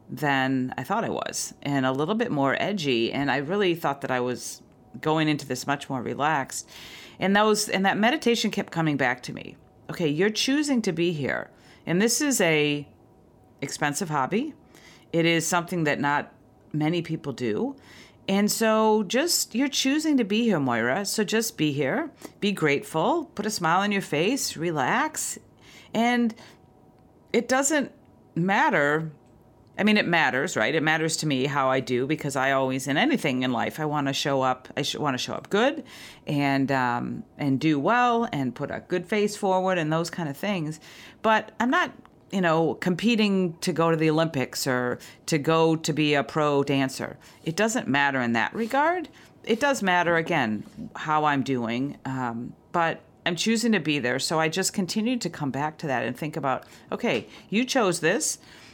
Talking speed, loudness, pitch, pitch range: 185 wpm, -25 LUFS, 160 Hz, 140-210 Hz